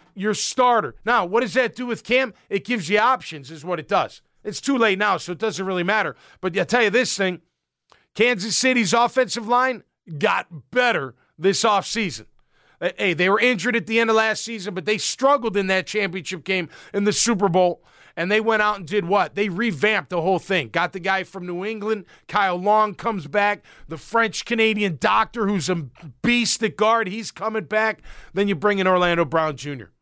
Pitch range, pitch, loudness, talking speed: 185-225 Hz, 210 Hz, -21 LUFS, 205 wpm